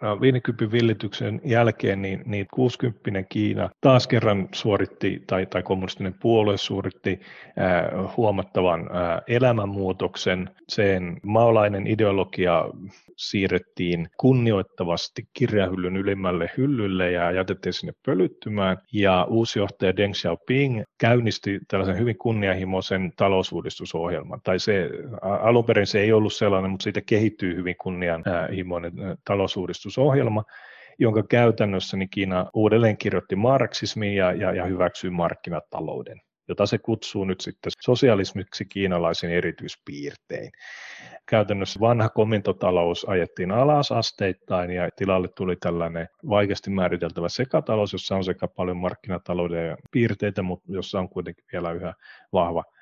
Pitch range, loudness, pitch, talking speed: 90-110 Hz, -24 LUFS, 100 Hz, 115 wpm